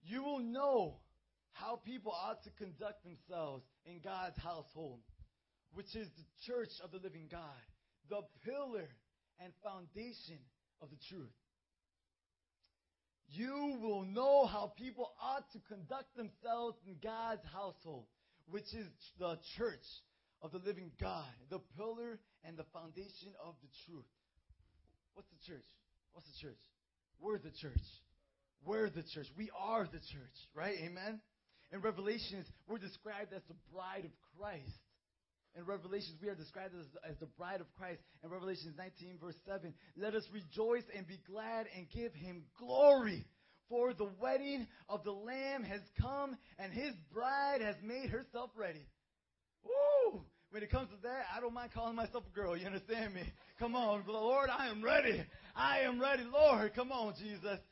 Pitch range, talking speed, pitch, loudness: 160-225 Hz, 160 wpm, 195 Hz, -41 LUFS